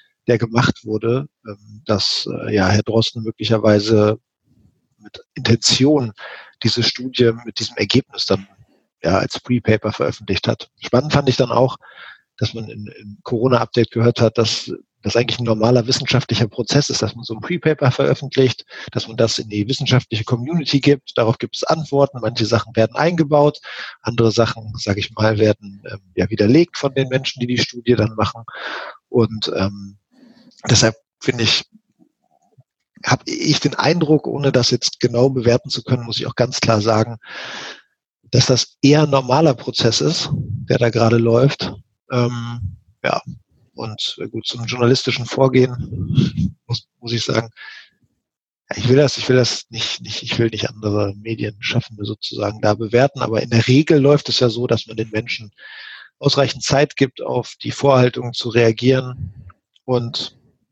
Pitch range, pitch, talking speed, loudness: 110-130 Hz, 120 Hz, 155 wpm, -18 LUFS